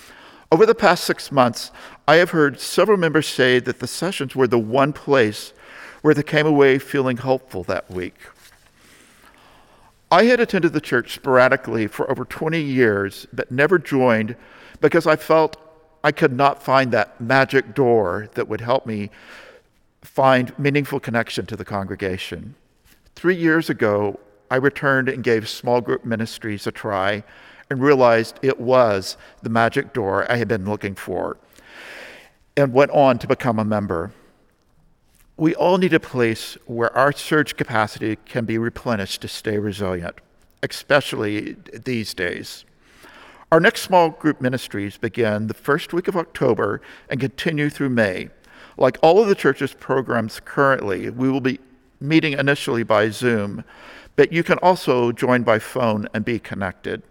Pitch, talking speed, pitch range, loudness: 130 Hz, 155 wpm, 110-145 Hz, -19 LUFS